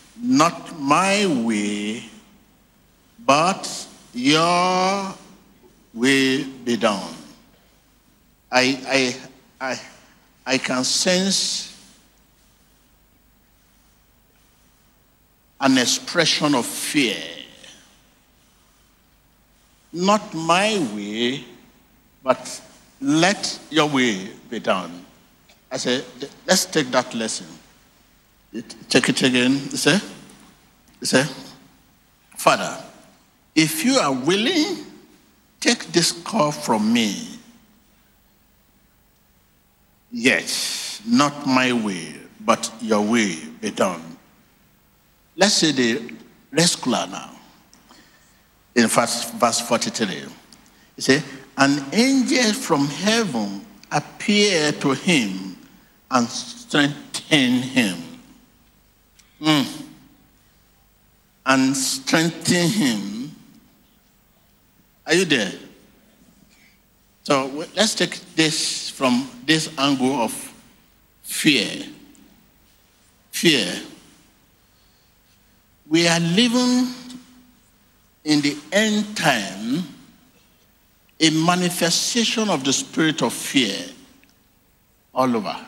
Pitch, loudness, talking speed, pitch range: 160 Hz, -20 LUFS, 80 wpm, 130-210 Hz